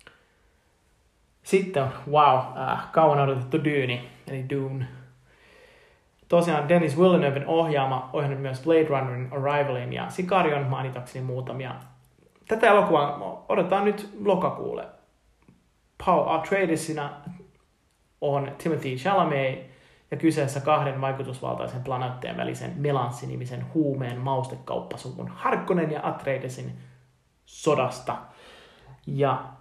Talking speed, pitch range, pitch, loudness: 95 wpm, 130-160 Hz, 140 Hz, -25 LUFS